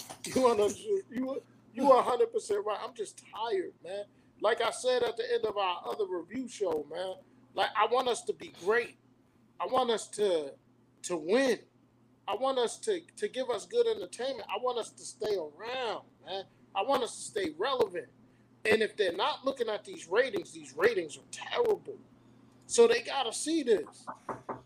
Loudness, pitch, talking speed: -31 LUFS, 360 Hz, 185 wpm